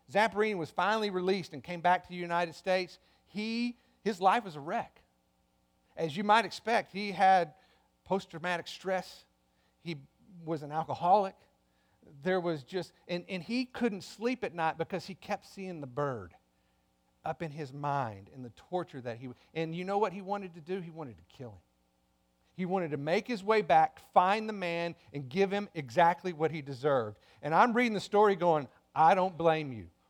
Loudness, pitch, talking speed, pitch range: -32 LUFS, 170 Hz, 190 wpm, 140-195 Hz